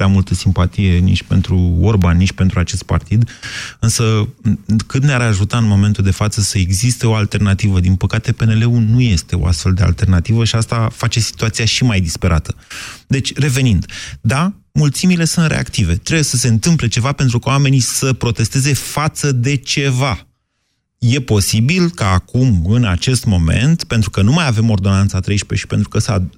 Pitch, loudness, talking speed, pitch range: 110 Hz, -15 LUFS, 170 wpm, 95-125 Hz